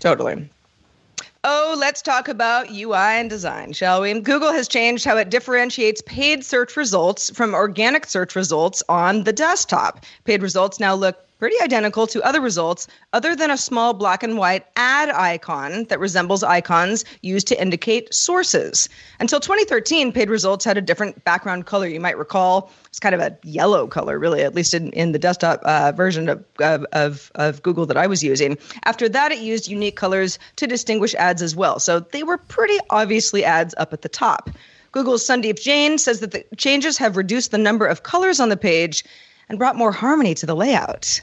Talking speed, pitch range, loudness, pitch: 190 wpm, 180-255 Hz, -19 LUFS, 215 Hz